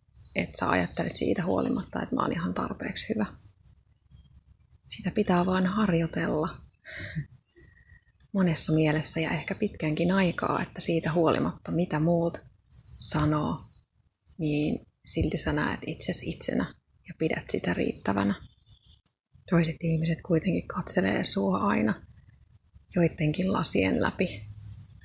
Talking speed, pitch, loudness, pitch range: 110 wpm, 160 Hz, -27 LUFS, 150-175 Hz